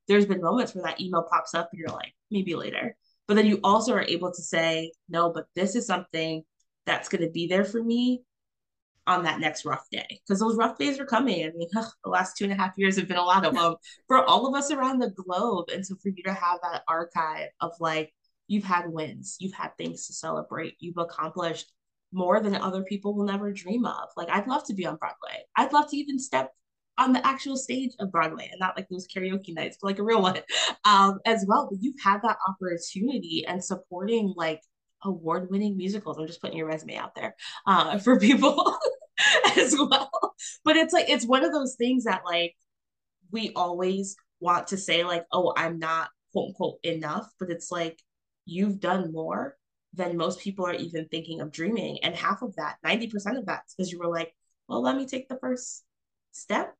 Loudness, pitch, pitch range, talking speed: -27 LUFS, 190 Hz, 170-230 Hz, 215 wpm